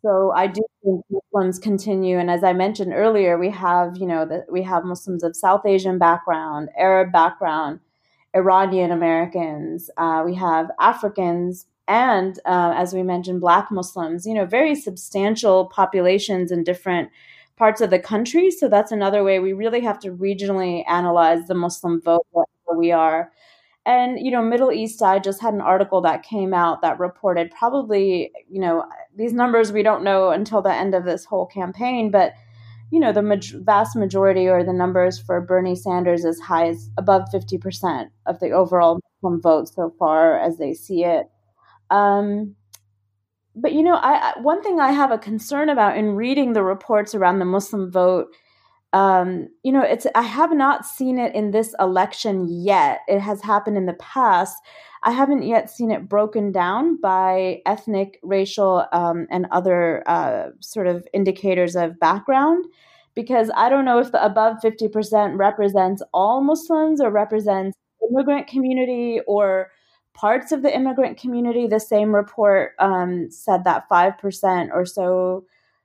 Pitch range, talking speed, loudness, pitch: 180-220 Hz, 170 wpm, -19 LUFS, 195 Hz